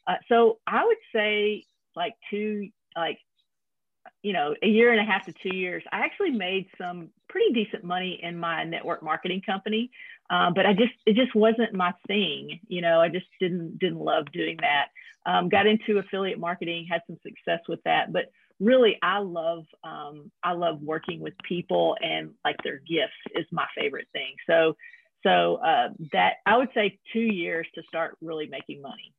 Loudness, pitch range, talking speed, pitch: -26 LUFS, 170-220 Hz, 185 wpm, 185 Hz